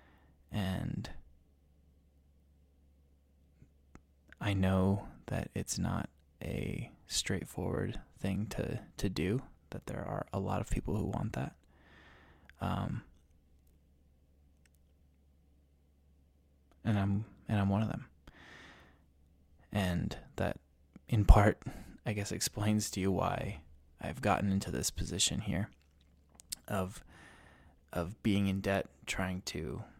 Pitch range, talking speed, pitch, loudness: 70-95 Hz, 105 wpm, 75 Hz, -35 LUFS